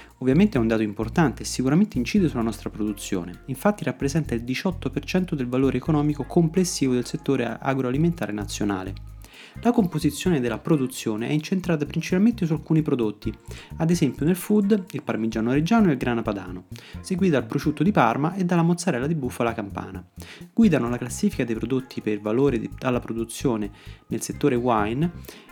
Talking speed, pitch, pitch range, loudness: 160 wpm, 130 Hz, 110-165 Hz, -24 LUFS